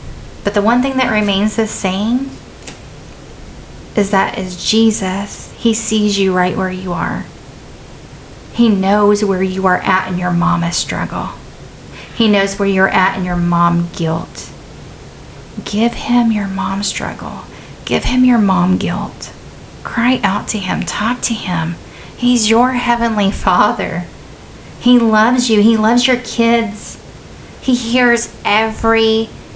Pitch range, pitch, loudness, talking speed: 190-230 Hz, 210 Hz, -14 LUFS, 140 wpm